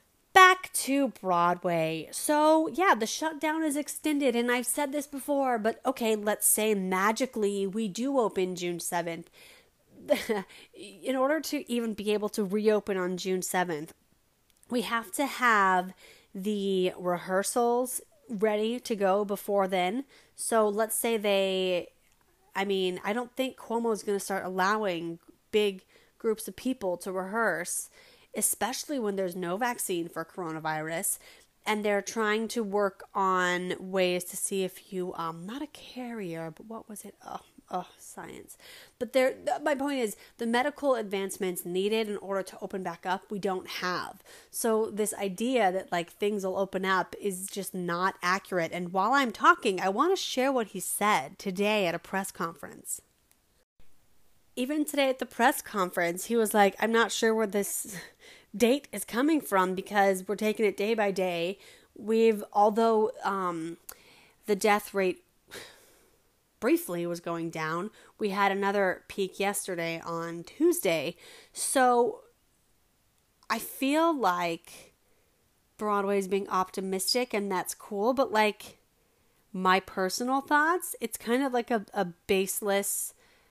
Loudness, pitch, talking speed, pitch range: -29 LUFS, 205 Hz, 150 wpm, 185-245 Hz